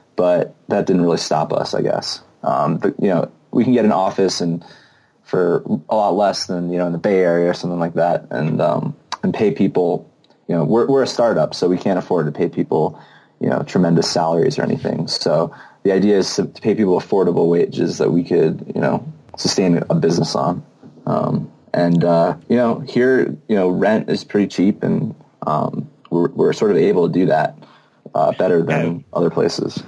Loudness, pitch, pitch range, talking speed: -18 LUFS, 90 Hz, 85-95 Hz, 205 wpm